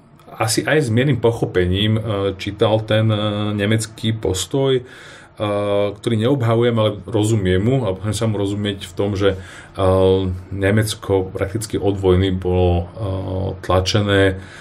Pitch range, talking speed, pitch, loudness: 95-110 Hz, 130 wpm, 100 Hz, -19 LUFS